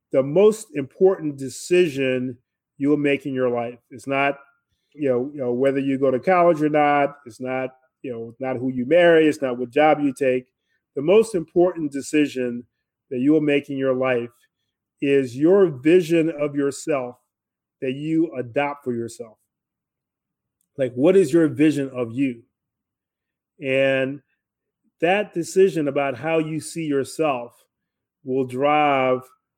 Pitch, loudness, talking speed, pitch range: 140 Hz, -21 LUFS, 150 wpm, 130-155 Hz